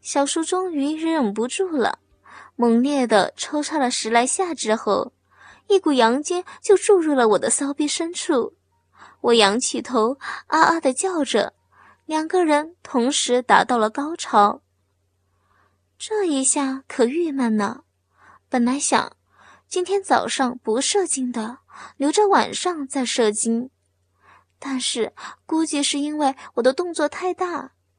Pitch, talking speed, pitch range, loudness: 270 Hz, 195 characters per minute, 230-325 Hz, -21 LUFS